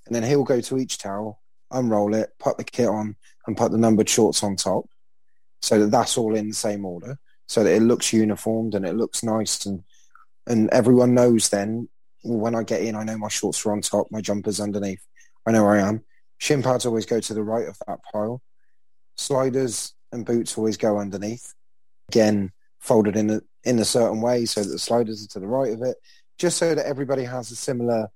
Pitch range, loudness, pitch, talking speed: 105-120 Hz, -22 LUFS, 110 Hz, 215 wpm